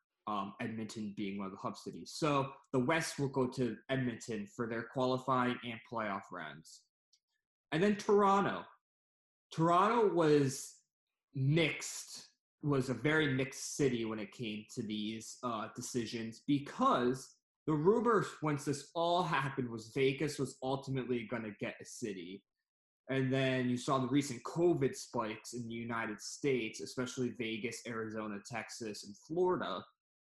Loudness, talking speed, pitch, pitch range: -36 LUFS, 145 wpm, 130 Hz, 115-145 Hz